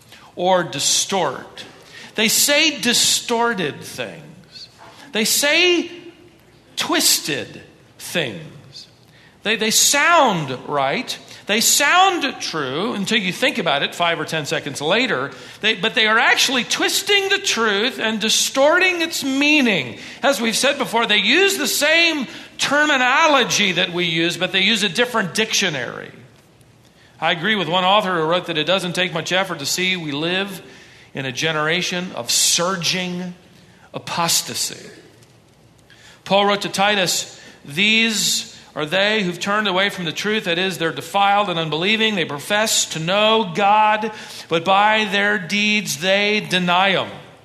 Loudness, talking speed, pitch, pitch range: -17 LUFS, 140 wpm, 200 Hz, 170-225 Hz